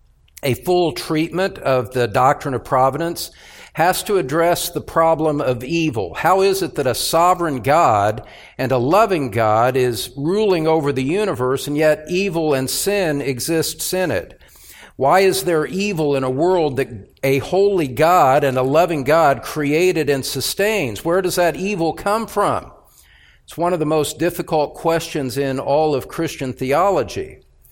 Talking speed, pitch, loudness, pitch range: 160 wpm, 155 Hz, -18 LUFS, 135-180 Hz